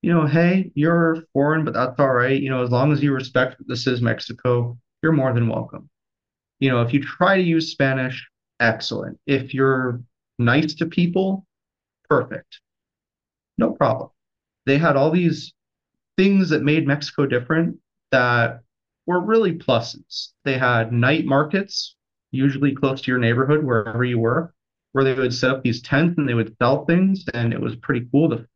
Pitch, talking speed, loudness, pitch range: 135 Hz, 175 wpm, -20 LUFS, 125-160 Hz